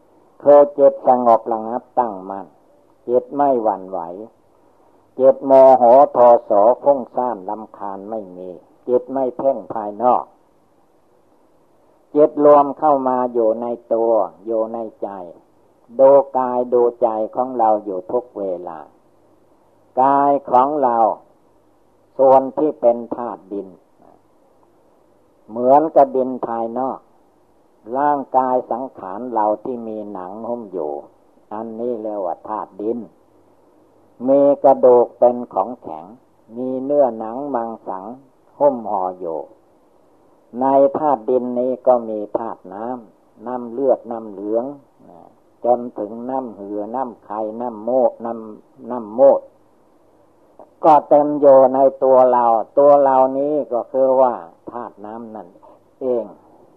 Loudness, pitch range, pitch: -17 LUFS, 110-135 Hz, 125 Hz